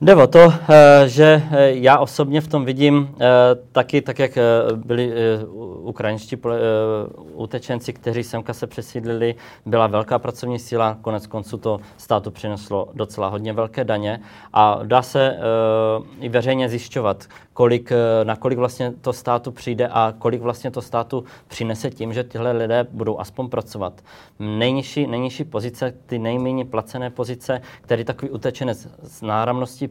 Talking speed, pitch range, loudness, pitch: 140 wpm, 110-130 Hz, -18 LUFS, 120 Hz